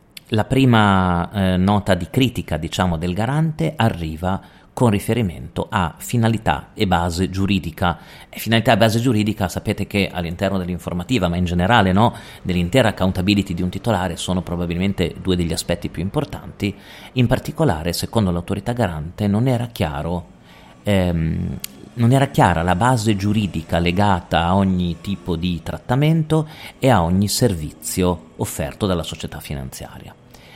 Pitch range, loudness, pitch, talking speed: 85-115 Hz, -20 LUFS, 95 Hz, 140 wpm